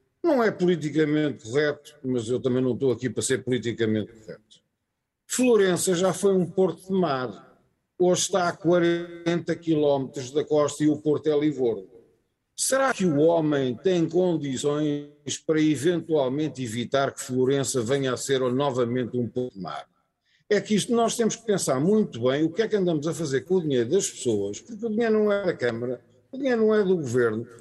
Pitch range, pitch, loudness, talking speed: 130-180 Hz, 150 Hz, -24 LUFS, 185 wpm